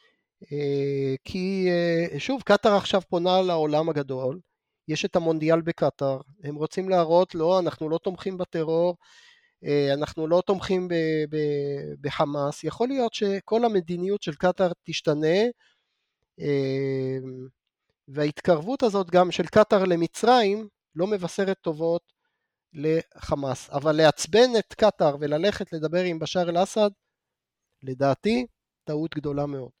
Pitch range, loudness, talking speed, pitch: 150-195 Hz, -25 LUFS, 115 wpm, 170 Hz